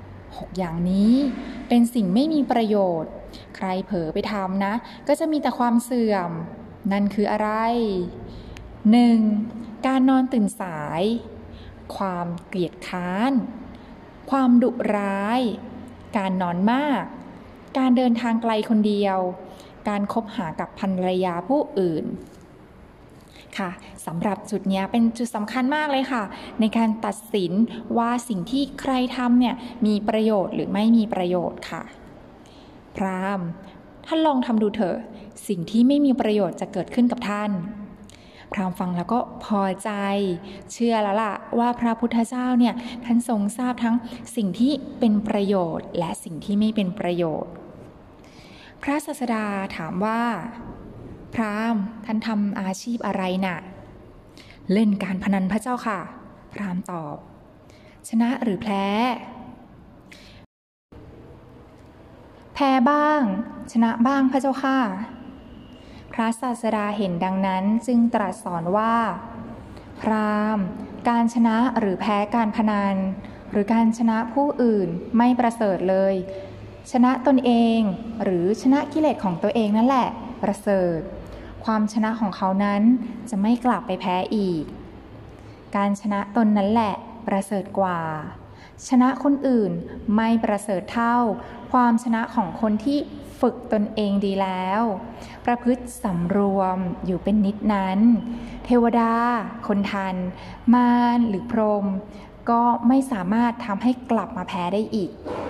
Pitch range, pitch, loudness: 195-240 Hz, 220 Hz, -23 LUFS